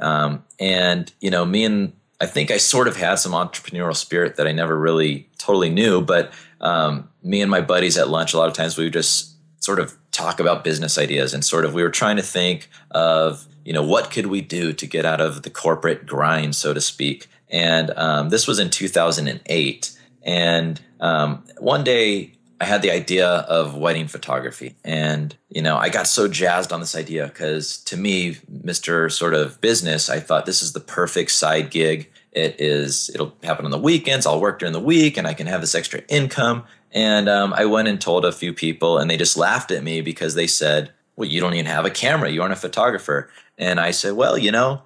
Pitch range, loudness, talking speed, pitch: 75-95 Hz, -19 LUFS, 220 wpm, 80 Hz